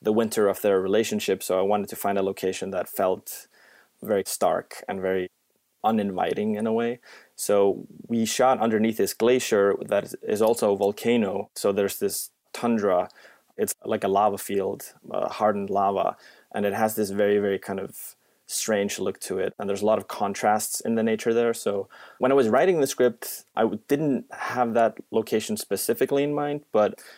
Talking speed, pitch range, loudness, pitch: 185 wpm, 100-115 Hz, -25 LUFS, 105 Hz